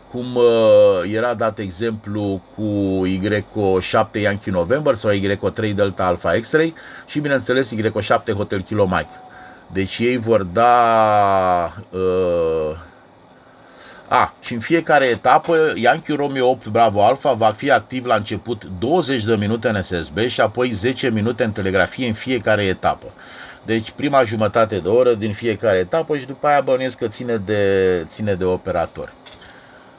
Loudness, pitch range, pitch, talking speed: -18 LUFS, 100-125 Hz, 115 Hz, 140 wpm